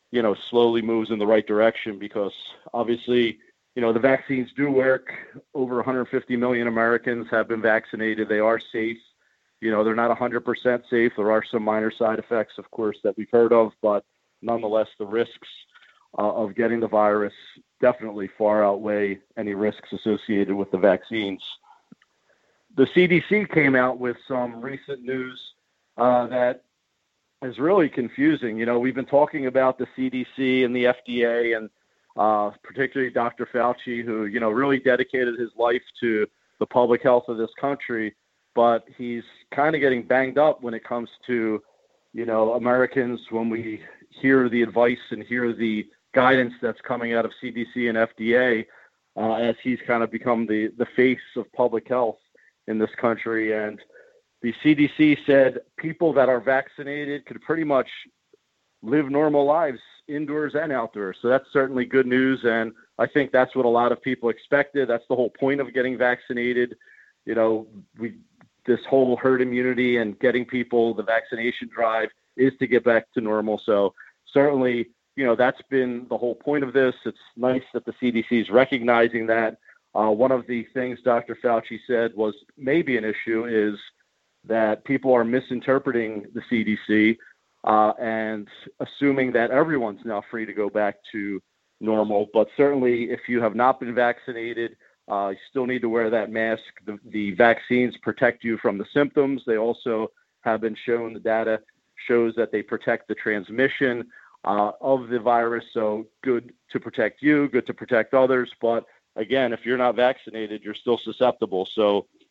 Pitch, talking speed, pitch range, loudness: 120 Hz, 170 wpm, 110-130 Hz, -23 LUFS